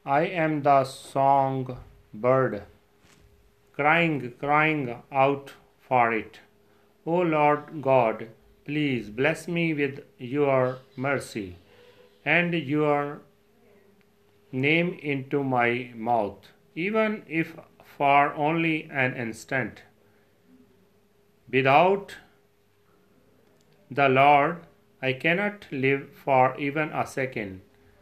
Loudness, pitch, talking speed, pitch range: -25 LUFS, 140 Hz, 90 wpm, 120-155 Hz